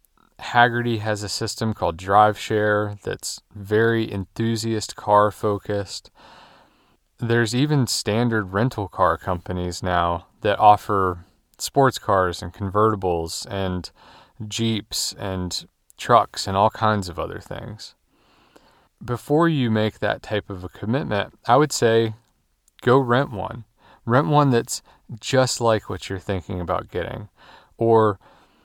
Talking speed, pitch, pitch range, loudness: 125 wpm, 105 Hz, 95-115 Hz, -22 LUFS